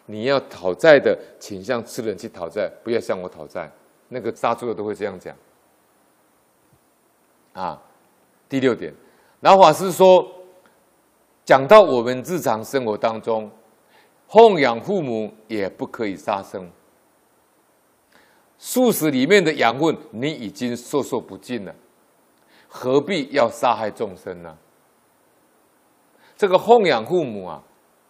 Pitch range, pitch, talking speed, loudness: 120-200 Hz, 140 Hz, 185 characters per minute, -19 LUFS